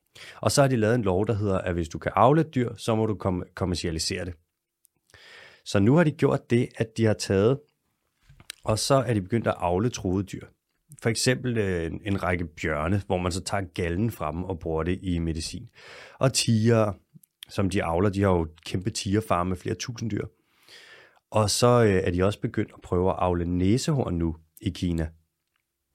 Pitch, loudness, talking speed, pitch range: 100 Hz, -26 LUFS, 200 wpm, 90-115 Hz